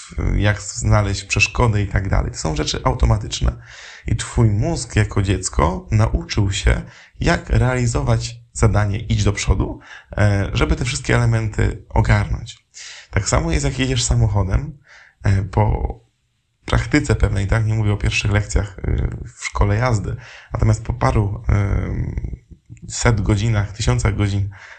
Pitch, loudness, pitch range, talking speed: 105 Hz, -19 LUFS, 100-115 Hz, 125 wpm